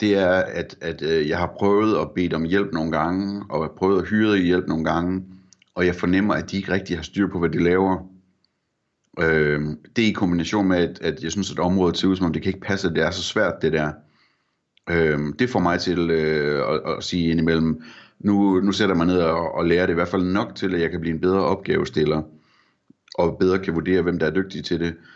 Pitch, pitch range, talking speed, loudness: 90 Hz, 80-95 Hz, 245 wpm, -22 LUFS